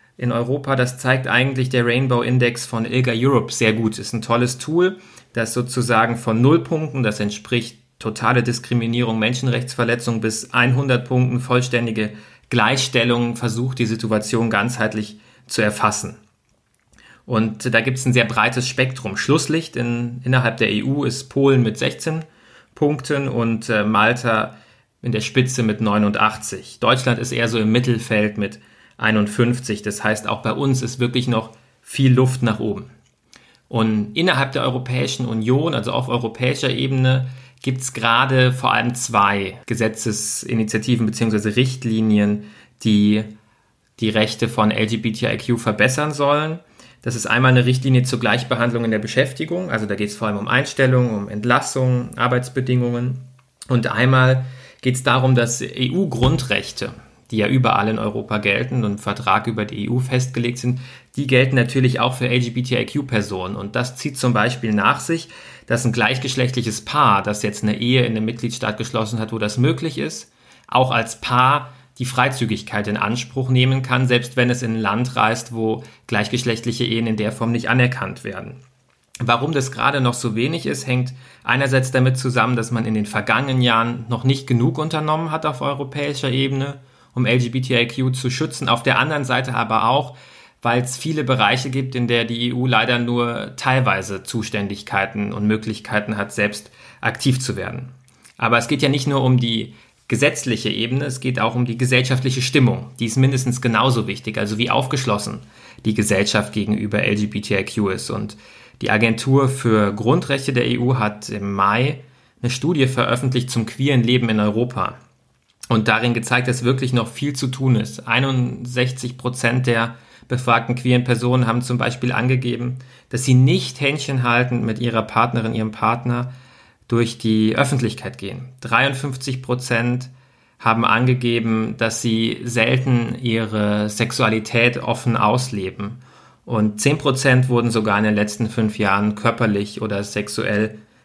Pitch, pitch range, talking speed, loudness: 120 Hz, 110-130 Hz, 155 wpm, -19 LUFS